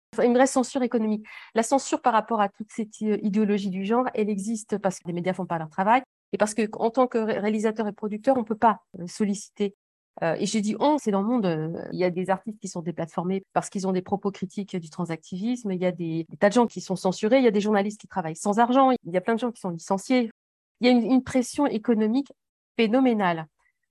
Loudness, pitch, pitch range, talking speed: -25 LUFS, 210 Hz, 190-235 Hz, 255 wpm